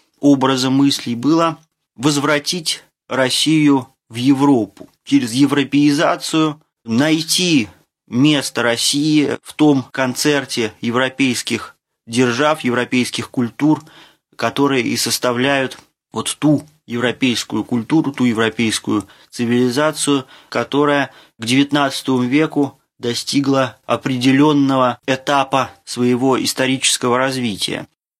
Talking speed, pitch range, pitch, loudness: 85 wpm, 125-145 Hz, 135 Hz, -17 LUFS